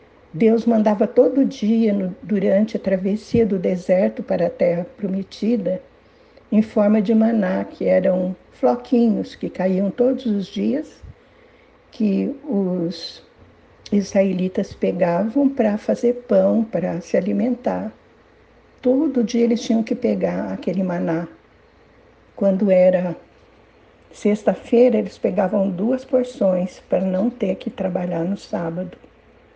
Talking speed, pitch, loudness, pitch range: 115 wpm, 205 Hz, -20 LUFS, 185-230 Hz